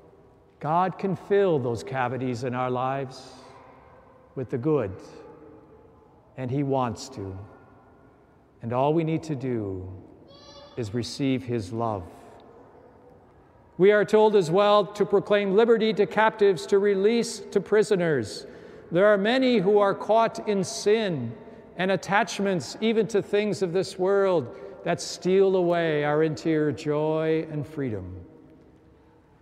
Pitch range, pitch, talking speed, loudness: 130-205 Hz, 170 Hz, 130 wpm, -24 LUFS